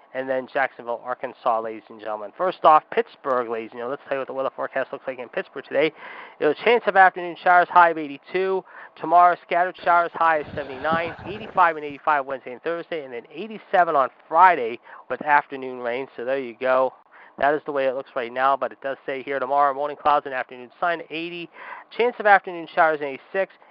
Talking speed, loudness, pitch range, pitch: 210 wpm, -22 LUFS, 130-175 Hz, 150 Hz